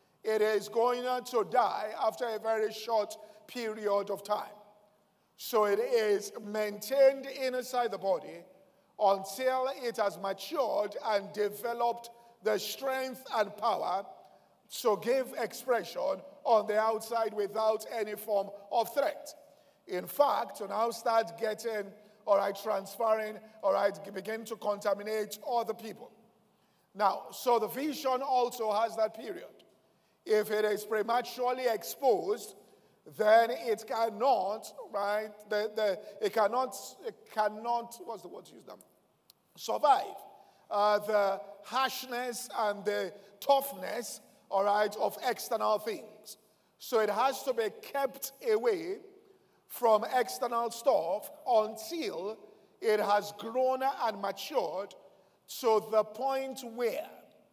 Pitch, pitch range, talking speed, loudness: 220 Hz, 210-255 Hz, 125 wpm, -32 LUFS